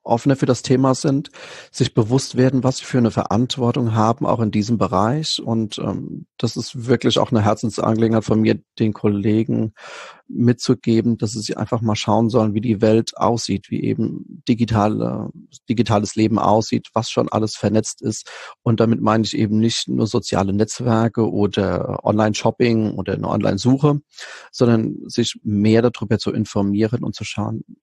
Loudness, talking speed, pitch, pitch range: -19 LUFS, 165 wpm, 110 Hz, 105-120 Hz